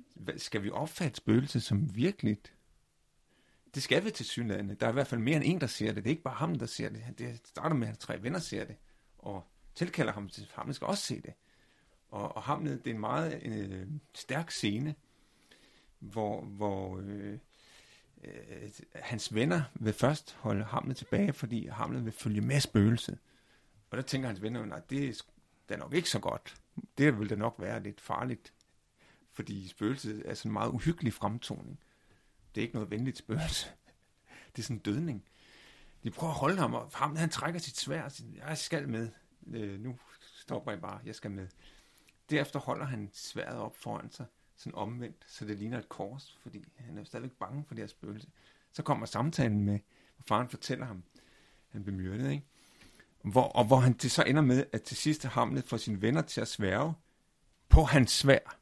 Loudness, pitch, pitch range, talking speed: -34 LUFS, 120 Hz, 105-140 Hz, 195 wpm